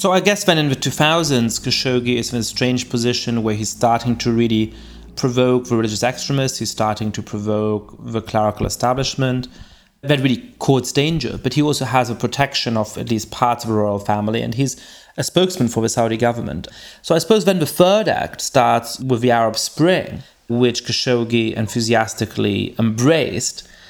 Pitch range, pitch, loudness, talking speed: 110-135 Hz, 120 Hz, -18 LUFS, 180 wpm